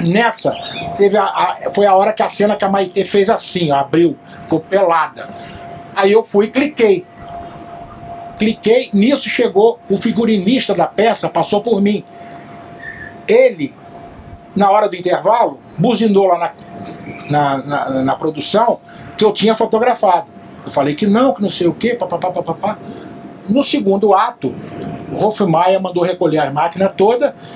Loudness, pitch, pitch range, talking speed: -15 LUFS, 200 Hz, 170-225 Hz, 165 wpm